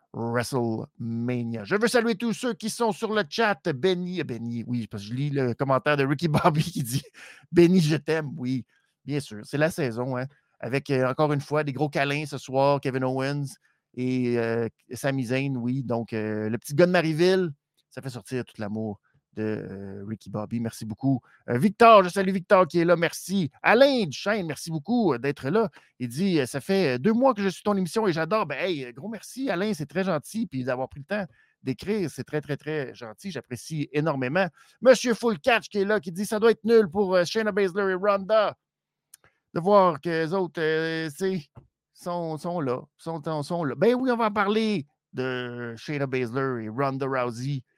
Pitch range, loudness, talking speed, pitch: 130-195 Hz, -25 LUFS, 200 wpm, 155 Hz